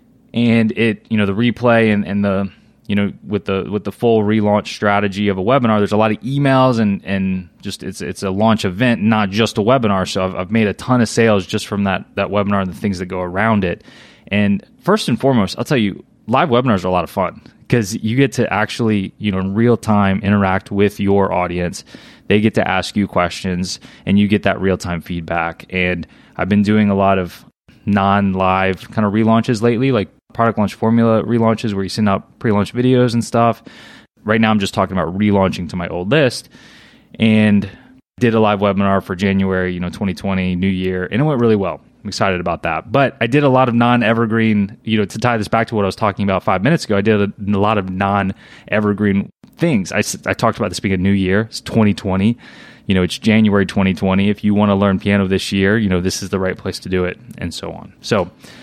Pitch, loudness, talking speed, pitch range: 100 Hz, -16 LUFS, 235 wpm, 95-110 Hz